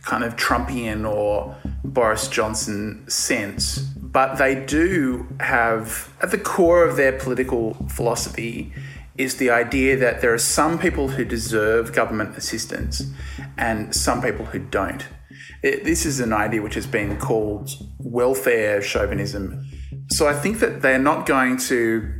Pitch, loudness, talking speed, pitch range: 115 Hz, -21 LUFS, 145 wpm, 105-130 Hz